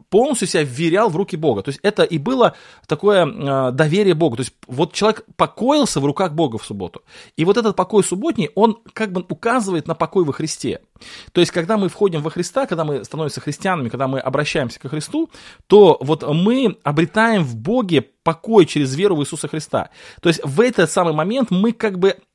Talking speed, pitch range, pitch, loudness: 200 wpm, 150-205 Hz, 170 Hz, -18 LUFS